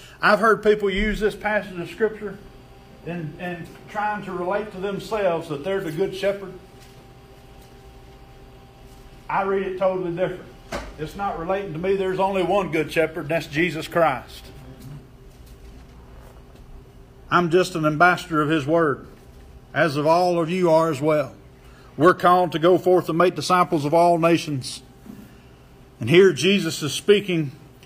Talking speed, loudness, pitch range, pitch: 150 wpm, -21 LUFS, 130-185 Hz, 165 Hz